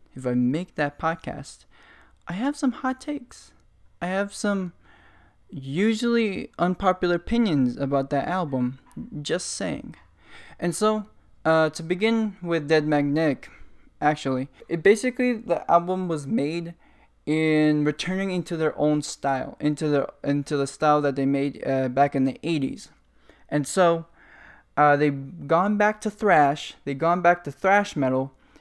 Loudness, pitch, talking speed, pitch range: -24 LUFS, 160 Hz, 145 wpm, 140-185 Hz